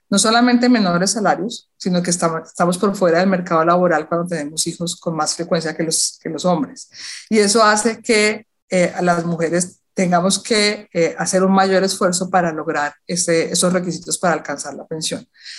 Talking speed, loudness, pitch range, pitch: 175 wpm, -17 LUFS, 170-195 Hz, 180 Hz